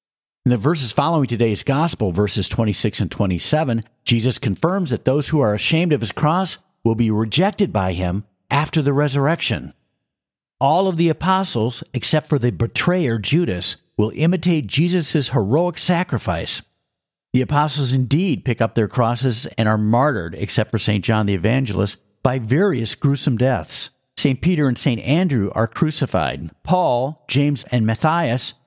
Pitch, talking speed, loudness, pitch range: 130 Hz, 155 wpm, -19 LUFS, 110-155 Hz